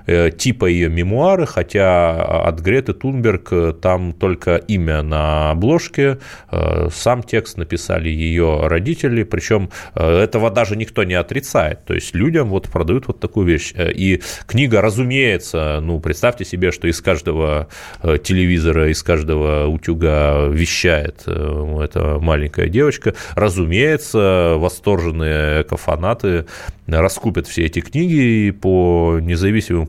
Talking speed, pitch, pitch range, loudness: 115 wpm, 90 Hz, 80-110 Hz, -17 LUFS